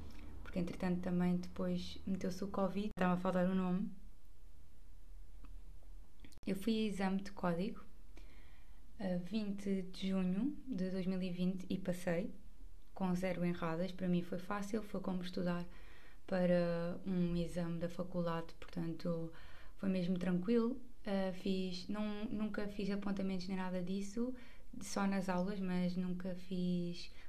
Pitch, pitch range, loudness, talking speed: 185 Hz, 175-195 Hz, -40 LUFS, 130 wpm